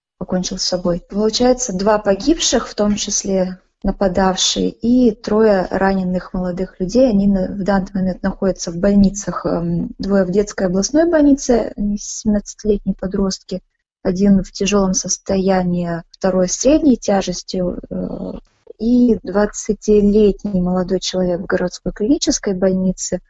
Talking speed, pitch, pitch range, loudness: 115 wpm, 195 Hz, 185-210 Hz, -17 LUFS